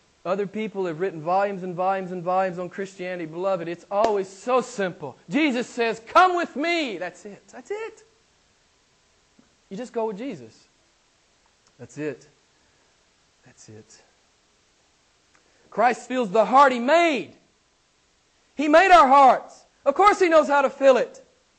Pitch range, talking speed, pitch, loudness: 185-290 Hz, 145 wpm, 225 Hz, -21 LUFS